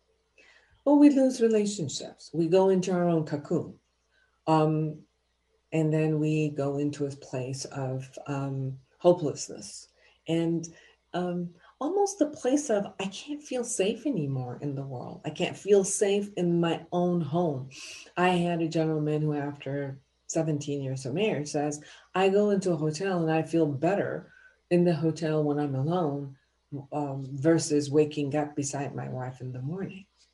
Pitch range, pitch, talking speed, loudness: 145-190 Hz, 160 Hz, 155 wpm, -28 LUFS